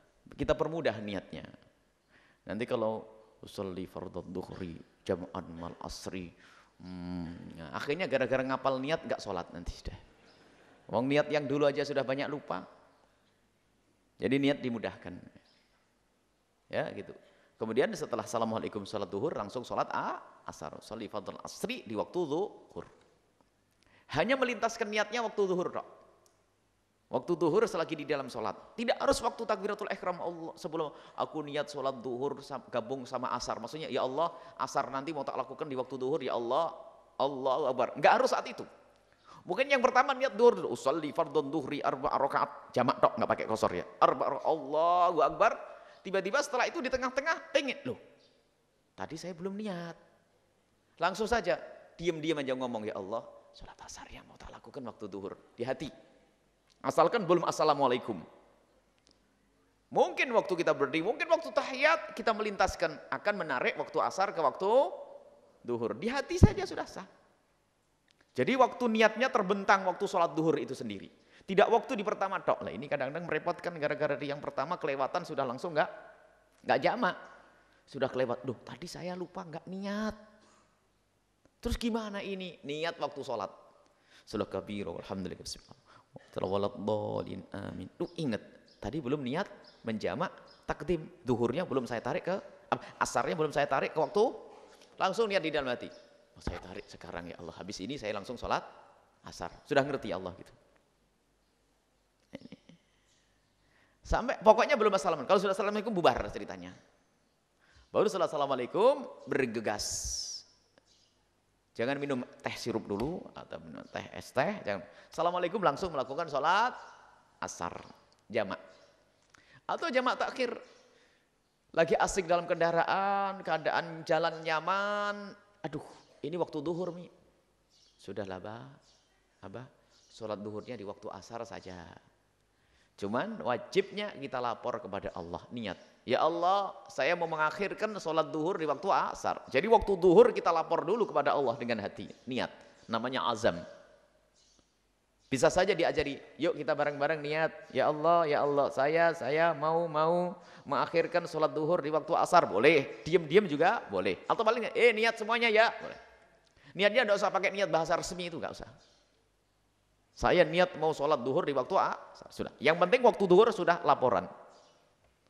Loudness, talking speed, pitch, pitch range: -31 LUFS, 140 wpm, 165 Hz, 130-205 Hz